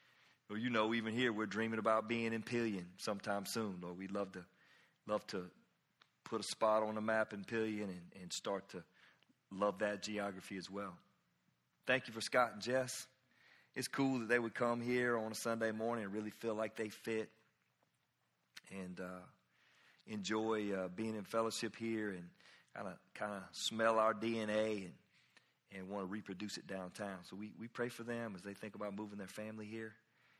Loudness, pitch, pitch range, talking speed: -41 LUFS, 110 Hz, 100-115 Hz, 185 wpm